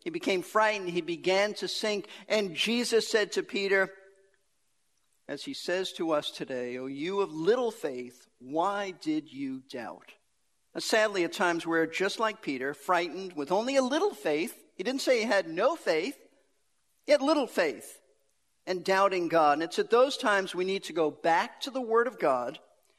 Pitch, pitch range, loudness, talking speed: 195 Hz, 170-235 Hz, -29 LUFS, 180 wpm